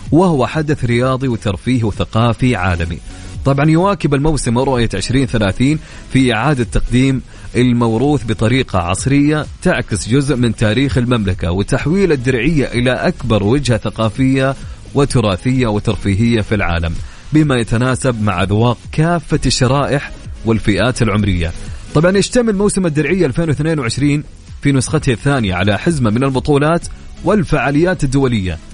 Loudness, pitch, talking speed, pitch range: -15 LUFS, 125 Hz, 115 wpm, 110-145 Hz